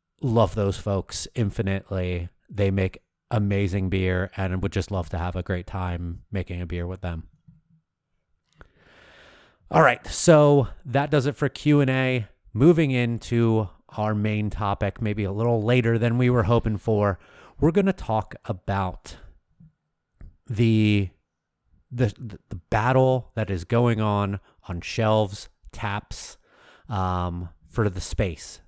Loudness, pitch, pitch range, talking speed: -24 LUFS, 105 Hz, 90-120 Hz, 135 wpm